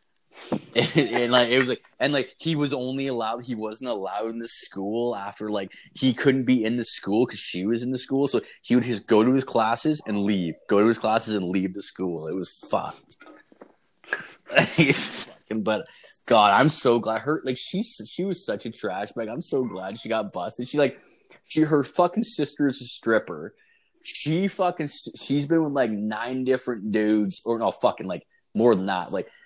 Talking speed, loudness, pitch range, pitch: 205 wpm, -24 LUFS, 110-150 Hz, 125 Hz